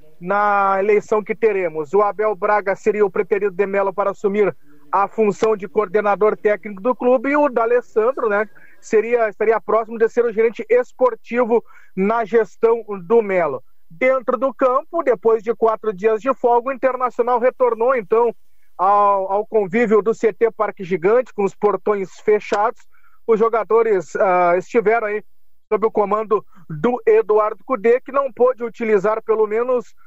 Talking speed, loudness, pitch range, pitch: 160 wpm, -18 LUFS, 205-245 Hz, 220 Hz